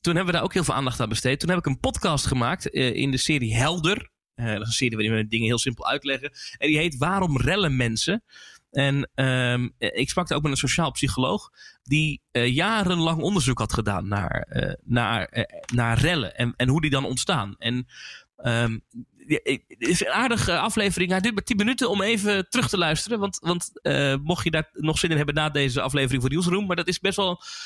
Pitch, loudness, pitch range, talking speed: 140 Hz, -24 LUFS, 125-180 Hz, 225 wpm